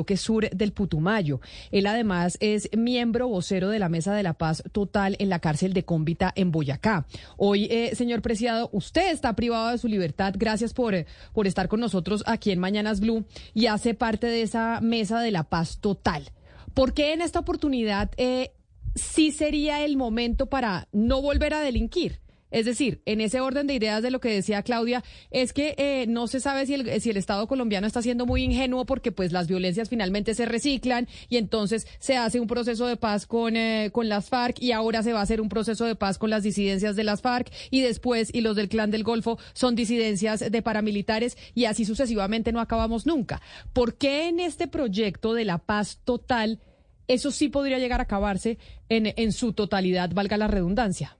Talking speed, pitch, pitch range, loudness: 200 wpm, 225 Hz, 205-245 Hz, -26 LUFS